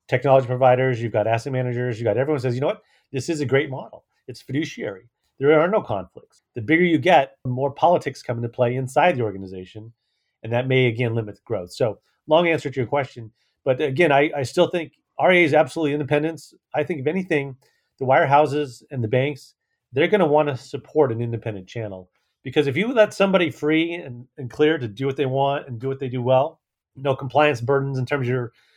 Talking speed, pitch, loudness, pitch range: 220 wpm, 135 Hz, -21 LUFS, 125-150 Hz